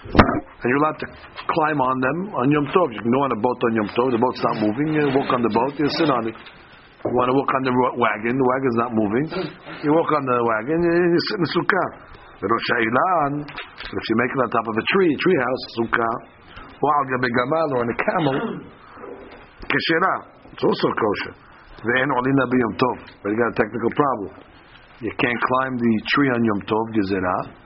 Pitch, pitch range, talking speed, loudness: 125 Hz, 115-145 Hz, 205 wpm, -21 LUFS